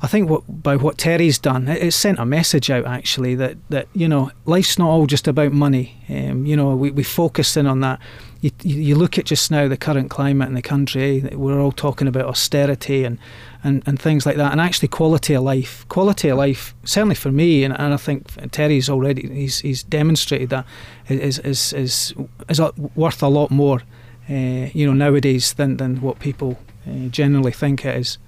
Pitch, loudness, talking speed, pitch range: 140 Hz, -18 LUFS, 210 wpm, 130-150 Hz